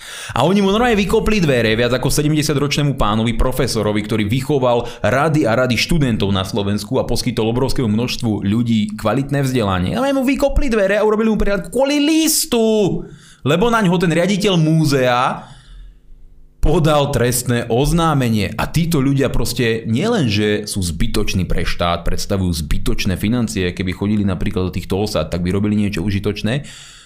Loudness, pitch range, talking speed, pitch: -17 LUFS, 105-160 Hz, 150 wpm, 120 Hz